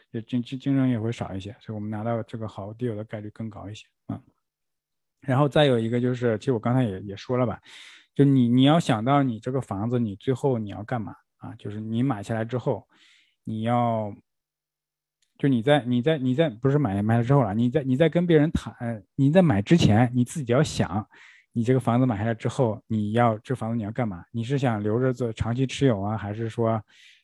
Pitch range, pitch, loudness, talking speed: 110-135 Hz, 120 Hz, -24 LUFS, 310 characters per minute